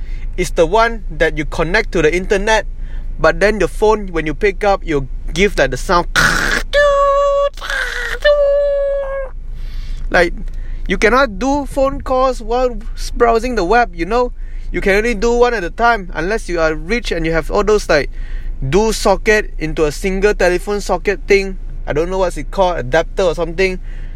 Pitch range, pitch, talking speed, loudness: 170-240 Hz, 205 Hz, 175 wpm, -15 LUFS